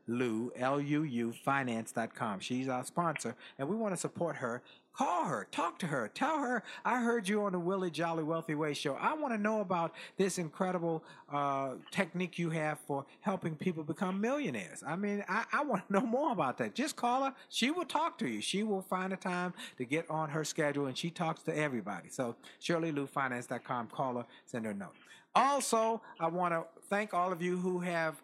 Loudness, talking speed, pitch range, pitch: -35 LUFS, 210 wpm, 145-205 Hz, 170 Hz